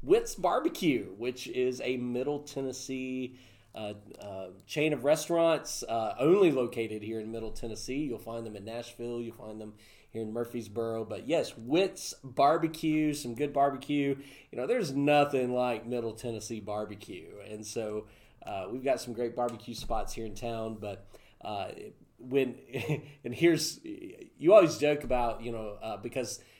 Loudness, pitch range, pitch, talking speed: -31 LUFS, 110-140 Hz, 120 Hz, 160 wpm